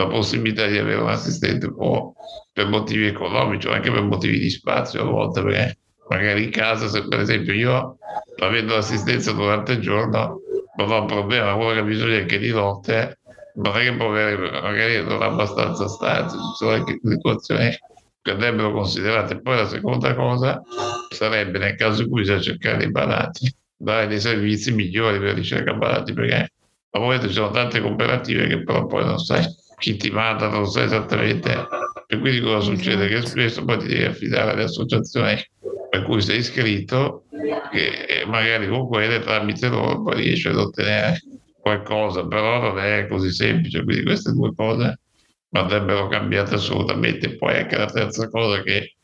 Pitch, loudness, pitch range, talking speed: 110 Hz, -21 LUFS, 100-115 Hz, 170 wpm